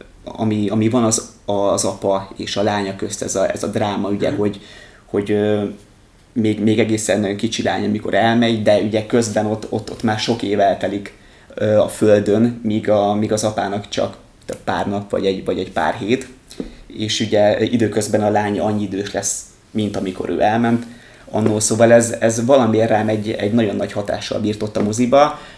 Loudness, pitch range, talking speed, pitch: -18 LUFS, 105-115 Hz, 180 wpm, 110 Hz